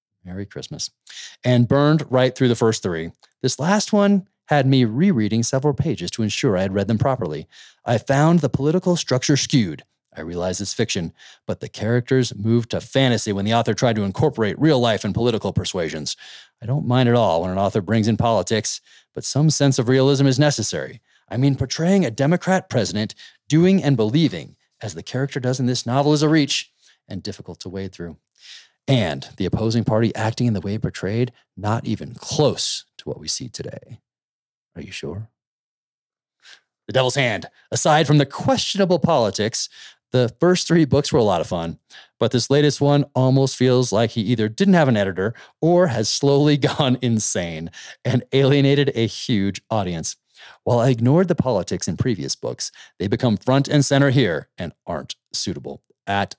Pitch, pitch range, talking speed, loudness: 125 Hz, 110-145 Hz, 180 wpm, -20 LUFS